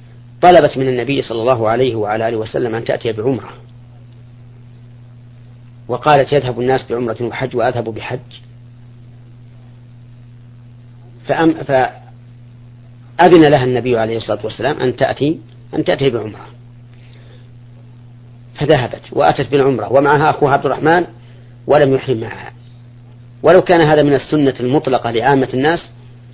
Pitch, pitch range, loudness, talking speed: 120 Hz, 120-130 Hz, -14 LUFS, 110 wpm